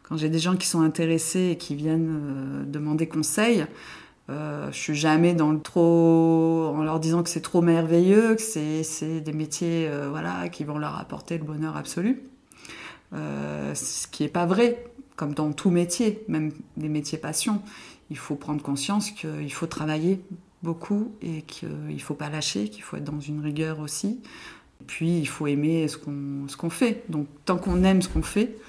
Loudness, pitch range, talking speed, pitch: -25 LUFS, 150-180 Hz, 195 wpm, 160 Hz